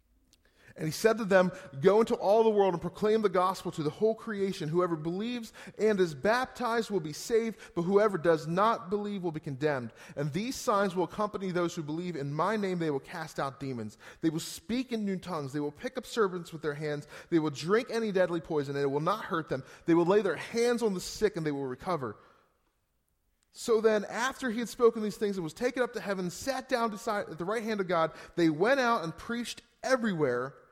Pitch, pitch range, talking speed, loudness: 185 Hz, 160-220 Hz, 230 wpm, -30 LUFS